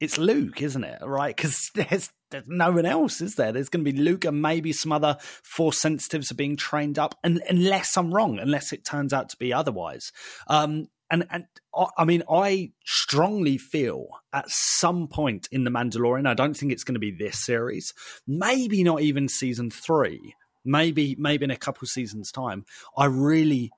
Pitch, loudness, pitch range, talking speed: 145 Hz, -25 LUFS, 130-165 Hz, 190 wpm